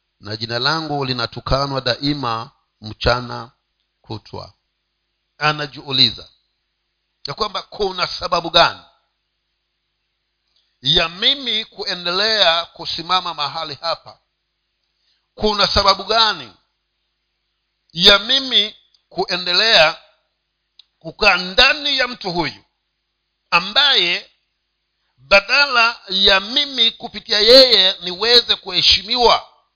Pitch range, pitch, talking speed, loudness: 145-215 Hz, 180 Hz, 75 wpm, -15 LUFS